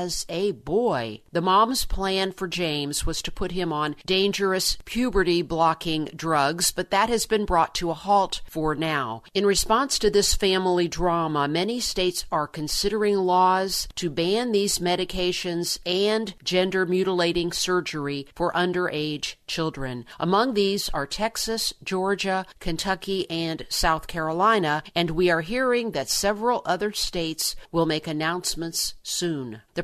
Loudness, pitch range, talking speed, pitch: -24 LUFS, 160-195 Hz, 140 wpm, 180 Hz